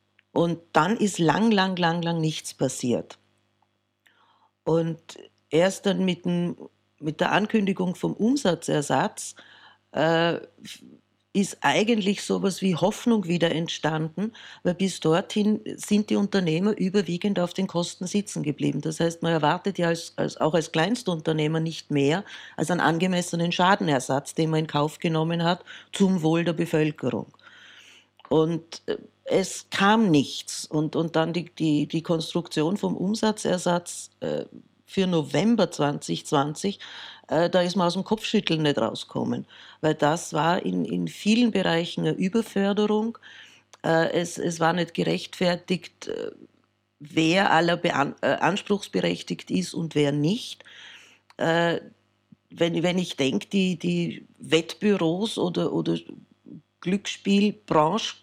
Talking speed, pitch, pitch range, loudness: 130 wpm, 170 Hz, 160-195 Hz, -25 LUFS